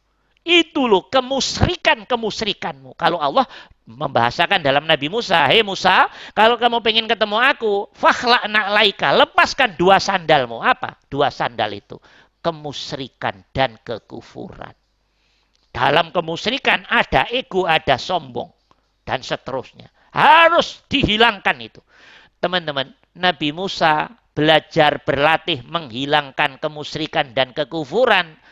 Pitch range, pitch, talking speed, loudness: 150-225 Hz, 175 Hz, 105 wpm, -17 LUFS